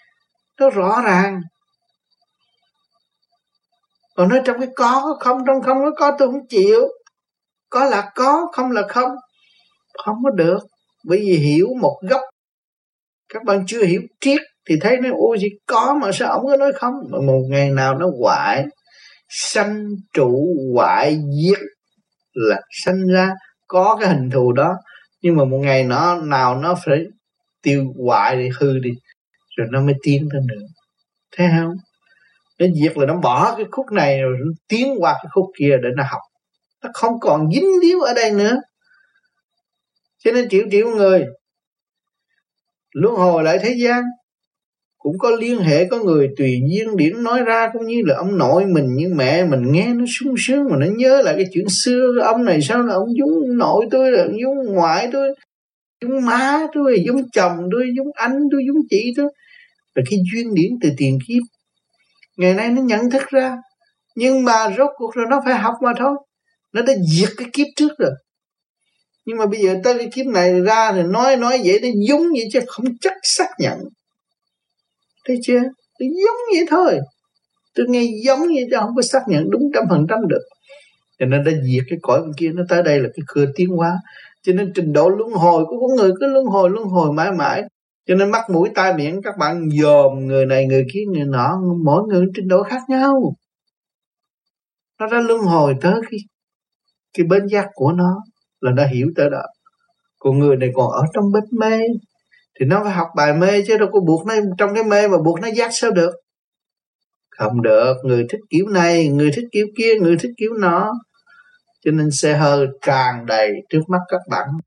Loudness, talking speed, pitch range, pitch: -17 LUFS, 195 wpm, 170-255 Hz, 210 Hz